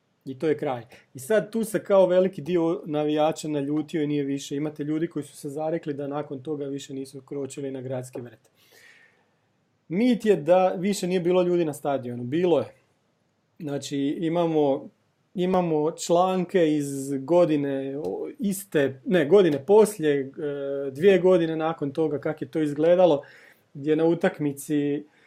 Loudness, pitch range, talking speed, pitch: -24 LUFS, 140-180 Hz, 150 wpm, 155 Hz